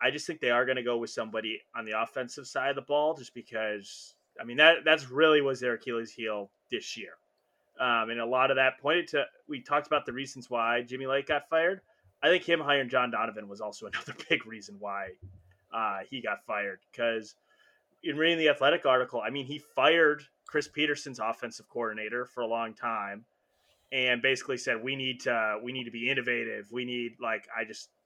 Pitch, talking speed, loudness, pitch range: 125 Hz, 210 wpm, -29 LUFS, 115-145 Hz